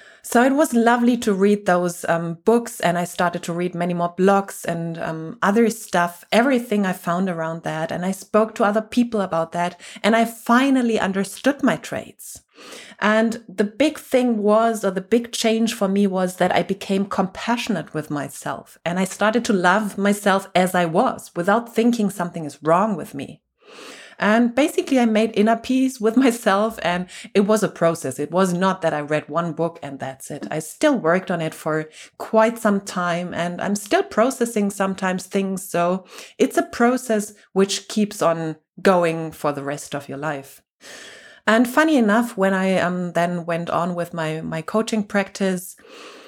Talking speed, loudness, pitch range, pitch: 185 wpm, -21 LUFS, 170-225 Hz, 195 Hz